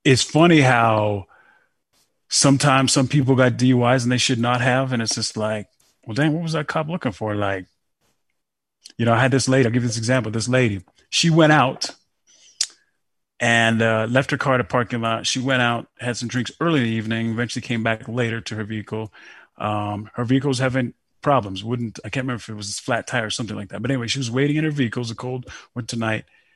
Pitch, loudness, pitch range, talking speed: 120 Hz, -20 LUFS, 110-130 Hz, 225 wpm